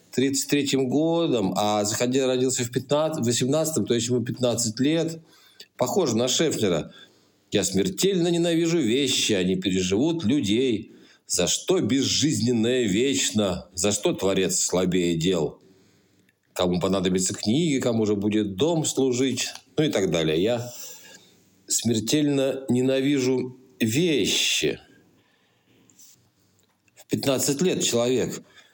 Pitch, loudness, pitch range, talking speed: 125 Hz, -23 LUFS, 105-140 Hz, 105 wpm